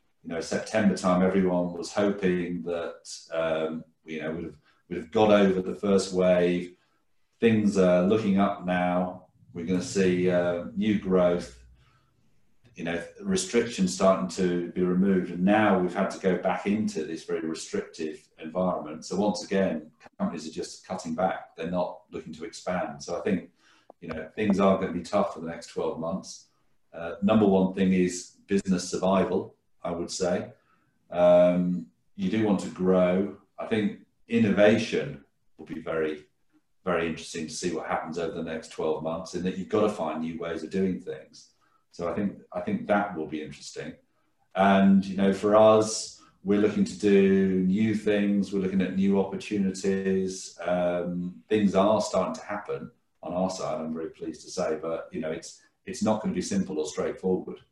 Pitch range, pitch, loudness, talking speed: 85-100 Hz, 95 Hz, -27 LUFS, 180 wpm